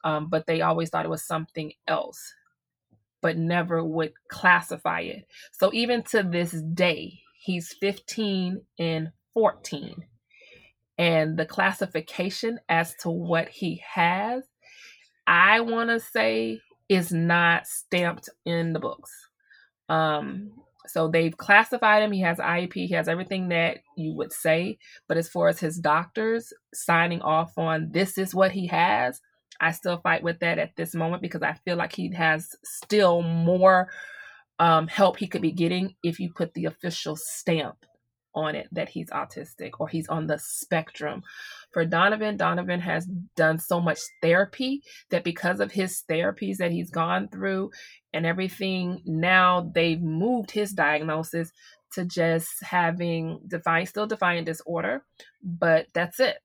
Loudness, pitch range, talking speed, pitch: -25 LUFS, 165-195 Hz, 150 wpm, 170 Hz